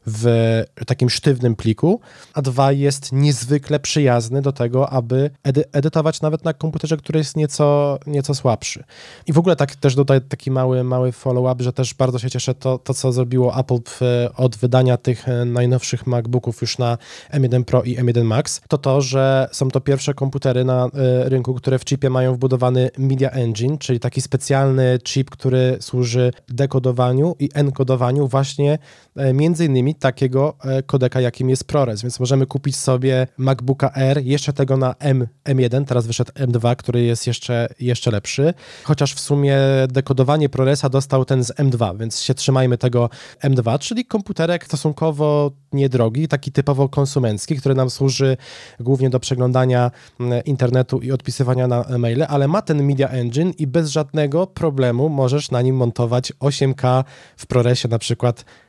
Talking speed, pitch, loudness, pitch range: 165 wpm, 130 Hz, -18 LUFS, 125-140 Hz